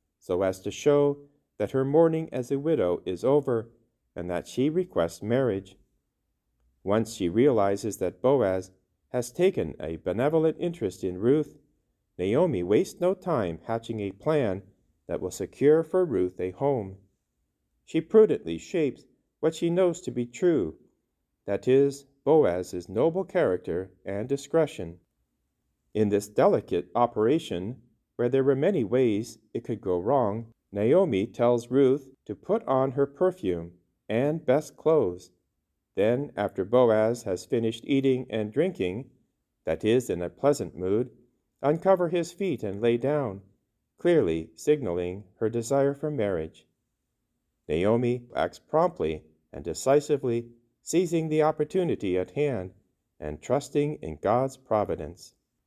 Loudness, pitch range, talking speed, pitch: -27 LUFS, 95-145 Hz, 135 wpm, 115 Hz